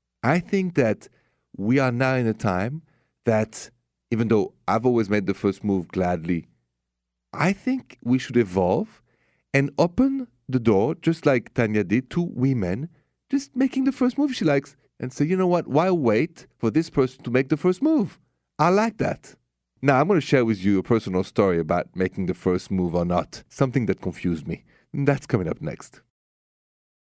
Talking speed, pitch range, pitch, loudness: 190 wpm, 95-160 Hz, 125 Hz, -23 LUFS